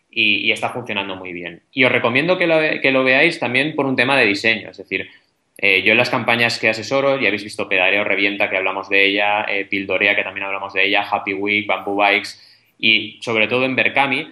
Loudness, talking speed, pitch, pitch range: -16 LUFS, 220 wpm, 105 Hz, 100-125 Hz